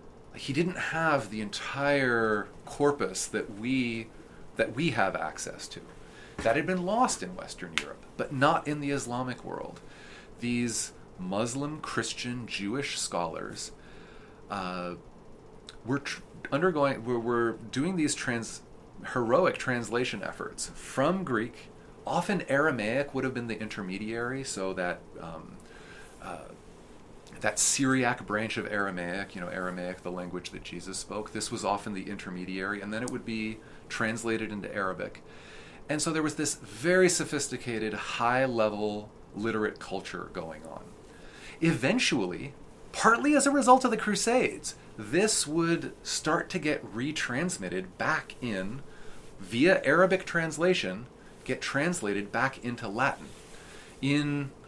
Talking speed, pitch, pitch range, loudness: 130 wpm, 120 Hz, 105-145 Hz, -30 LUFS